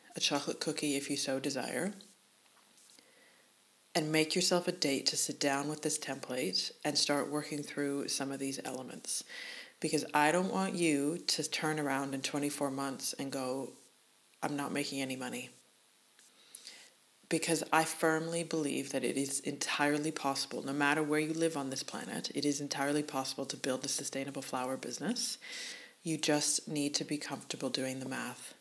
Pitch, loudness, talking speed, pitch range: 150 Hz, -34 LUFS, 170 wpm, 140-160 Hz